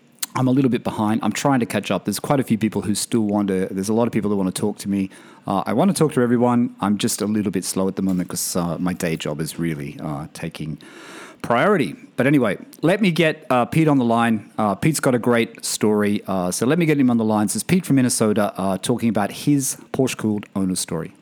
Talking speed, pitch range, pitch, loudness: 265 wpm, 95-130 Hz, 110 Hz, -20 LUFS